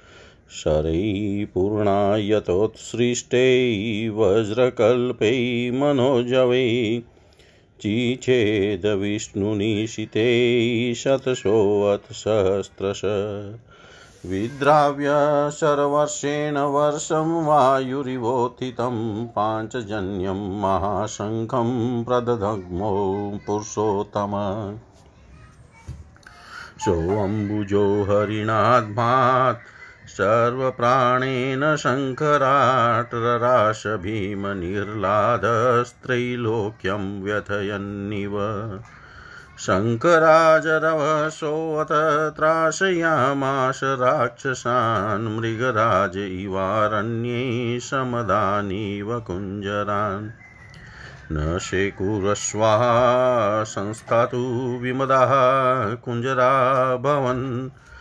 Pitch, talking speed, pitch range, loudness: 115 Hz, 35 wpm, 105-130 Hz, -21 LUFS